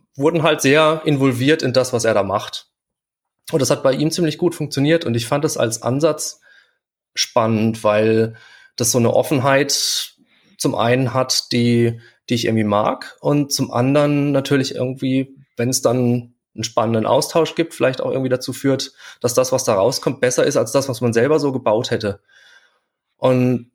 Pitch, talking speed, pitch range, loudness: 130 Hz, 180 wpm, 120-145 Hz, -18 LUFS